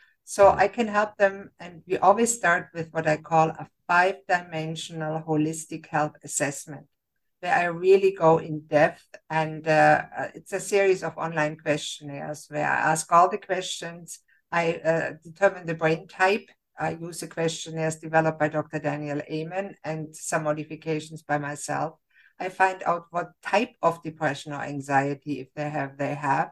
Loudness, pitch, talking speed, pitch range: -25 LUFS, 160 Hz, 165 wpm, 150-175 Hz